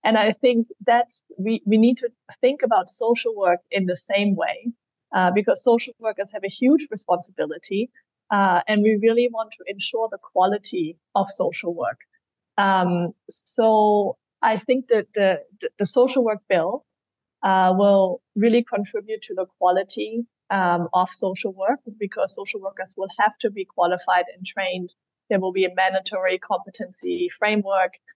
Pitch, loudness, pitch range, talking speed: 205 Hz, -22 LUFS, 190-235 Hz, 160 wpm